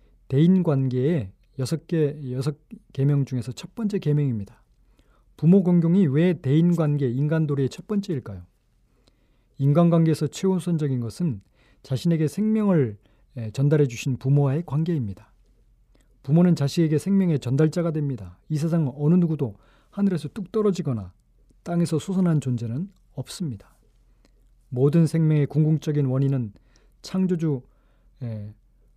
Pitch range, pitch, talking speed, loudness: 130-170 Hz, 145 Hz, 295 characters per minute, -23 LUFS